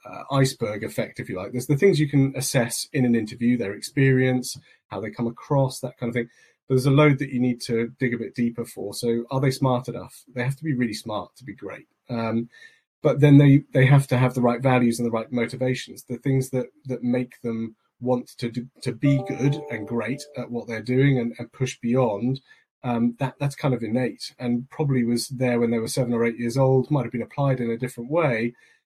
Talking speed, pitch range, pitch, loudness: 235 wpm, 120-135 Hz, 125 Hz, -24 LUFS